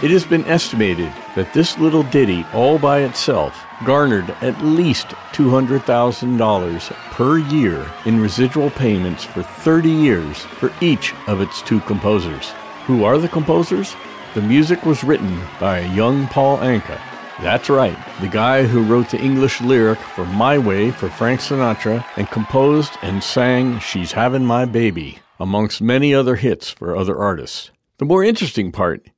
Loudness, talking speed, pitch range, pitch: -17 LUFS, 155 wpm, 105-145 Hz, 125 Hz